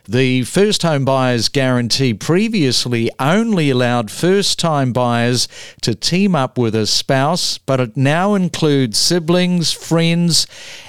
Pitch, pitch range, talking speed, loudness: 135 Hz, 125-170 Hz, 125 wpm, -15 LUFS